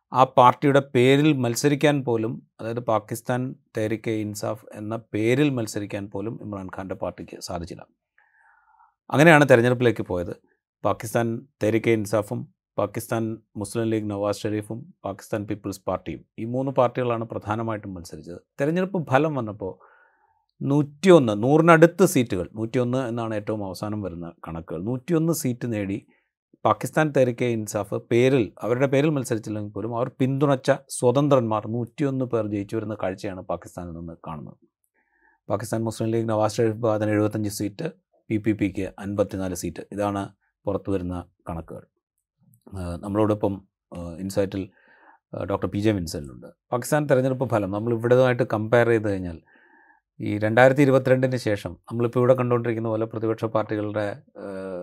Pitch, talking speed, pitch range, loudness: 110 Hz, 120 wpm, 100-125 Hz, -23 LUFS